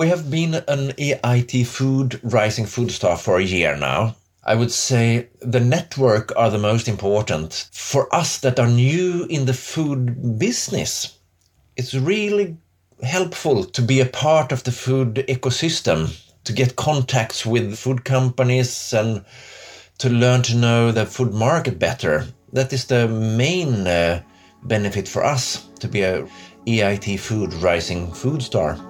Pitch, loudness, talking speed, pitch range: 125 Hz, -20 LUFS, 150 wpm, 105-130 Hz